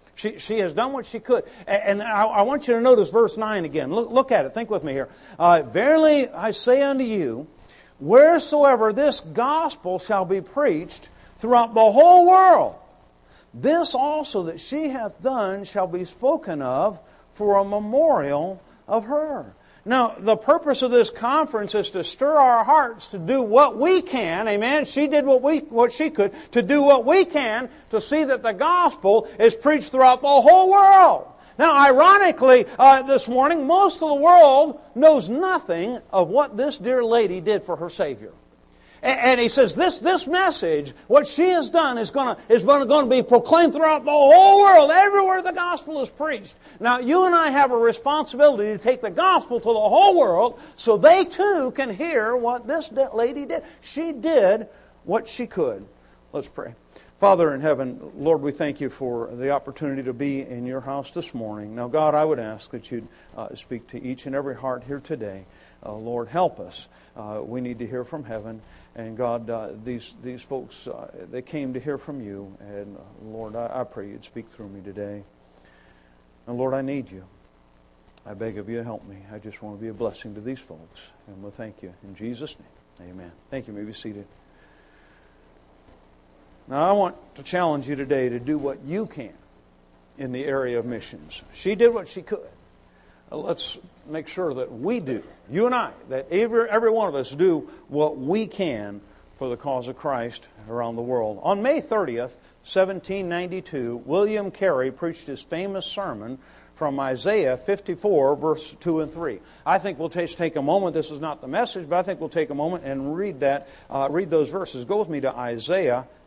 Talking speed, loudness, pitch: 195 wpm, -20 LUFS, 195 Hz